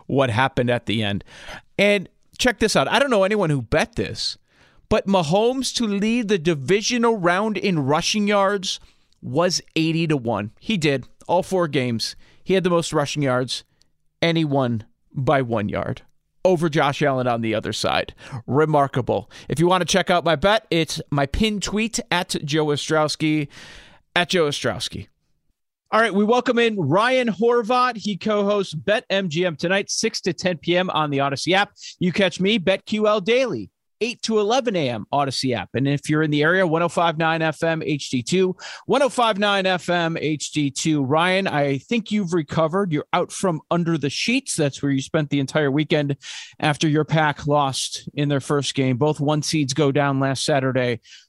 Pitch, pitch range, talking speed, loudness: 160 Hz, 140-195 Hz, 175 wpm, -21 LUFS